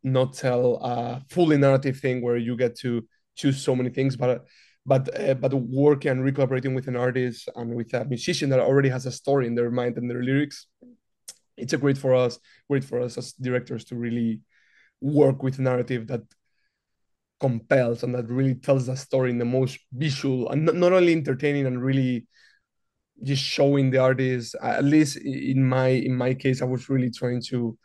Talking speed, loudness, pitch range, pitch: 190 wpm, -24 LUFS, 125-135 Hz, 130 Hz